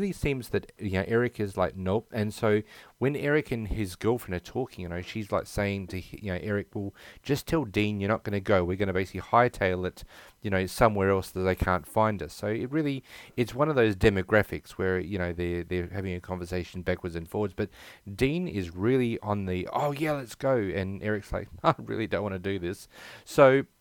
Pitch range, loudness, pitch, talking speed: 95-115 Hz, -29 LUFS, 100 Hz, 230 wpm